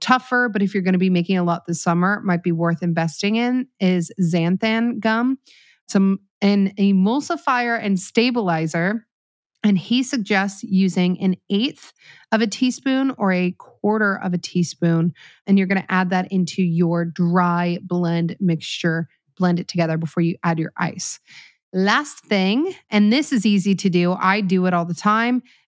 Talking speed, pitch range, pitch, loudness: 170 wpm, 175-220 Hz, 190 Hz, -20 LUFS